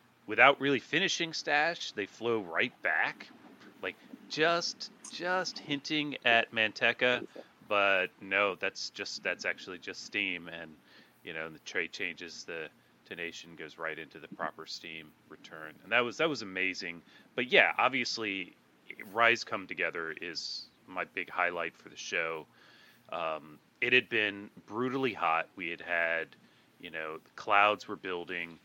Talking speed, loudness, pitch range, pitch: 150 wpm, -31 LUFS, 85-135 Hz, 110 Hz